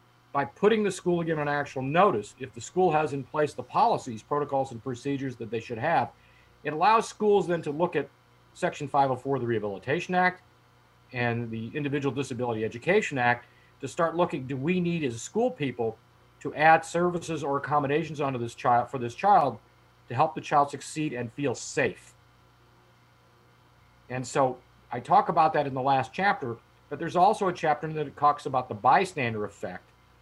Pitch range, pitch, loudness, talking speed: 120-160 Hz, 140 Hz, -27 LUFS, 185 wpm